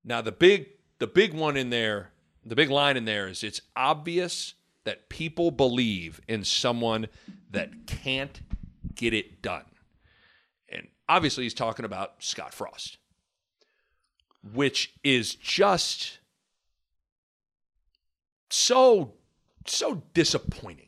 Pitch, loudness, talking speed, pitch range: 115 Hz, -26 LUFS, 110 wpm, 90-140 Hz